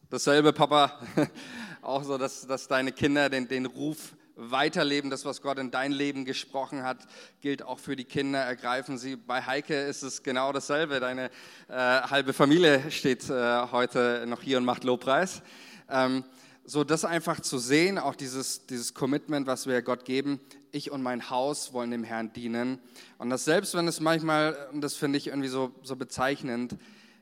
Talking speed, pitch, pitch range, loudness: 175 wpm, 135 Hz, 125-145 Hz, -28 LUFS